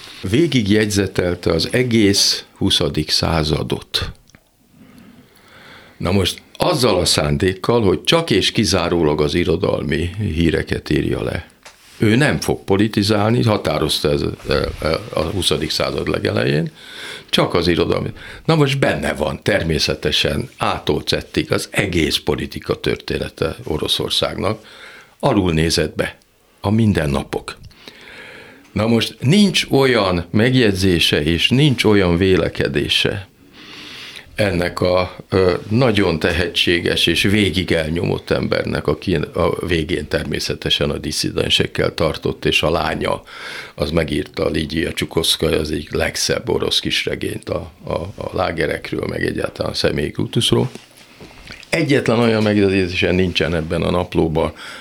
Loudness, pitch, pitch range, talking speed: -18 LUFS, 95 Hz, 85-110 Hz, 110 wpm